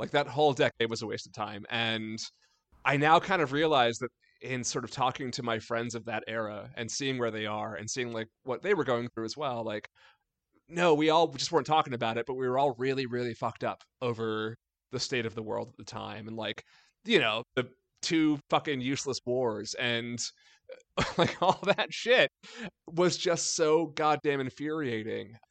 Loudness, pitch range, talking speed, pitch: -30 LUFS, 115-150 Hz, 200 wpm, 125 Hz